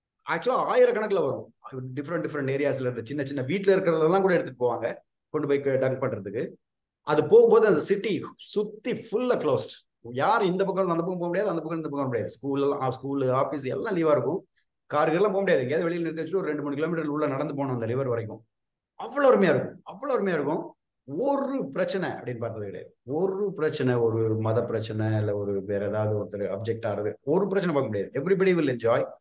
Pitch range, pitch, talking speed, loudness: 115-175 Hz, 140 Hz, 185 wpm, -26 LUFS